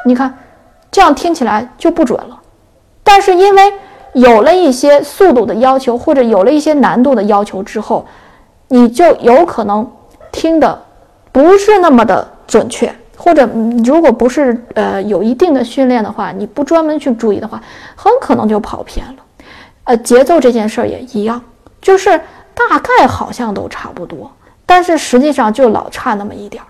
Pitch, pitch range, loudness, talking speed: 265 Hz, 230-330 Hz, -10 LUFS, 260 characters per minute